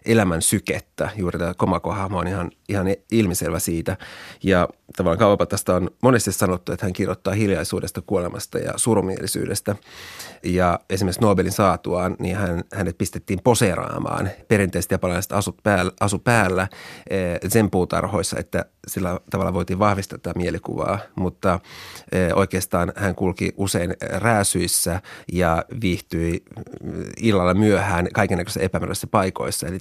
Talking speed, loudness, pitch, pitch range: 125 wpm, -22 LUFS, 95 Hz, 90-100 Hz